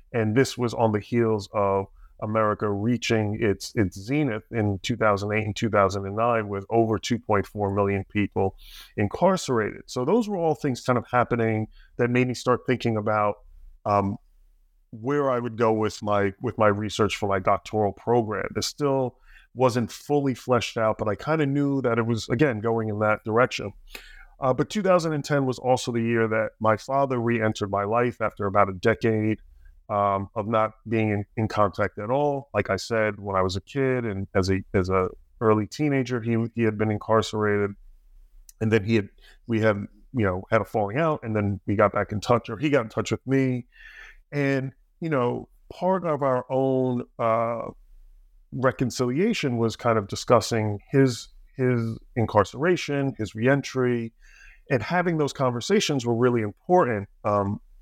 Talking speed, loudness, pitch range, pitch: 175 wpm, -25 LUFS, 105-125 Hz, 115 Hz